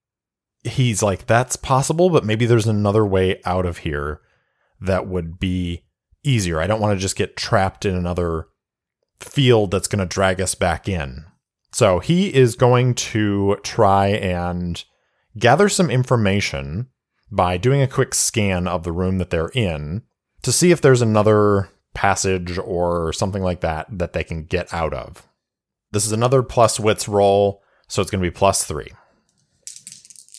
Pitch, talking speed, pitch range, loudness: 100 Hz, 165 wpm, 90-115 Hz, -19 LUFS